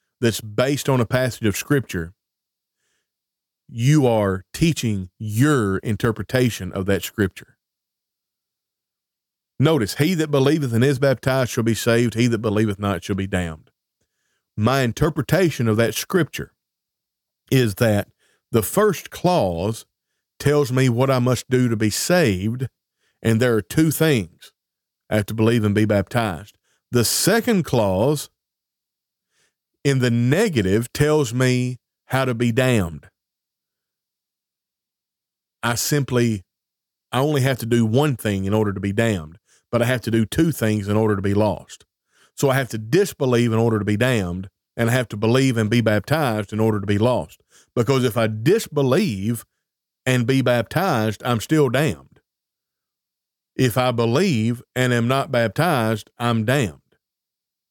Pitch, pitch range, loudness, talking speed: 120 Hz, 105-135 Hz, -20 LUFS, 150 wpm